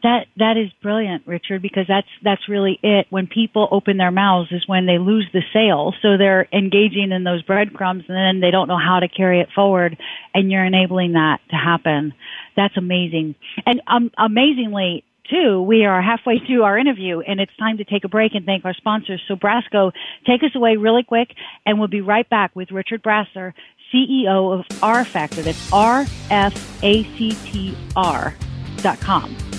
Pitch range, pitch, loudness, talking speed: 185-220 Hz, 200 Hz, -17 LUFS, 185 wpm